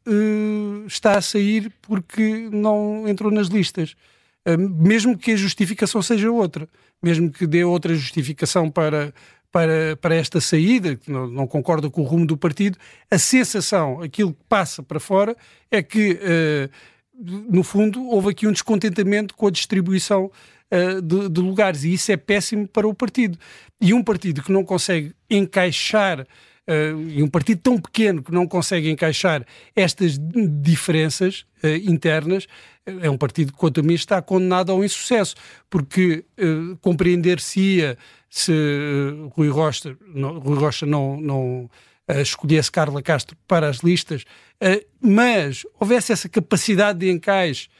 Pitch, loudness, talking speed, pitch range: 180 Hz, -20 LUFS, 155 wpm, 155-205 Hz